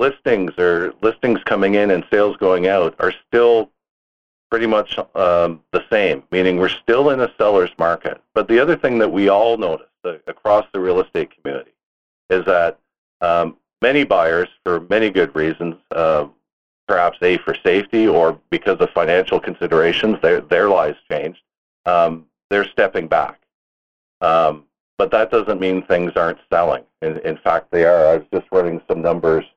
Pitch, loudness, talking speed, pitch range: 100 Hz, -17 LUFS, 165 wpm, 80-120 Hz